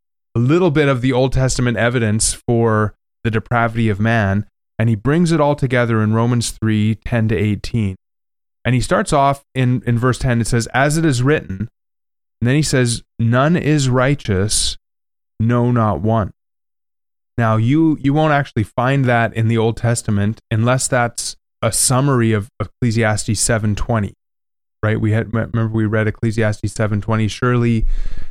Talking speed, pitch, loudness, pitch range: 165 wpm, 115 Hz, -17 LUFS, 110-125 Hz